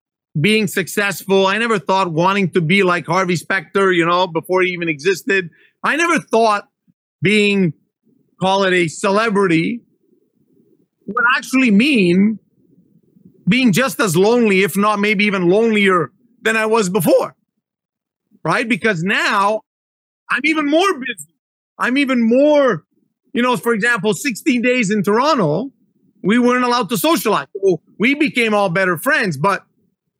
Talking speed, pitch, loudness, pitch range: 140 wpm, 210 Hz, -16 LUFS, 190-240 Hz